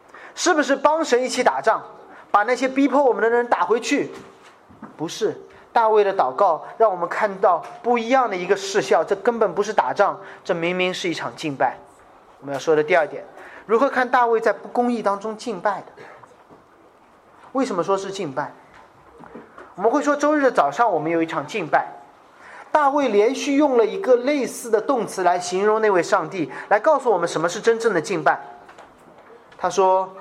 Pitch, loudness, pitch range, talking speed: 230 Hz, -20 LUFS, 200-275 Hz, 270 characters per minute